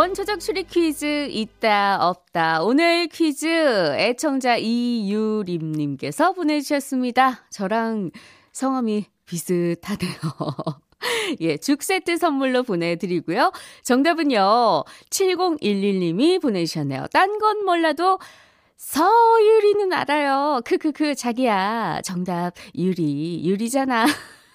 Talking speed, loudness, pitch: 225 characters per minute, -21 LUFS, 255 Hz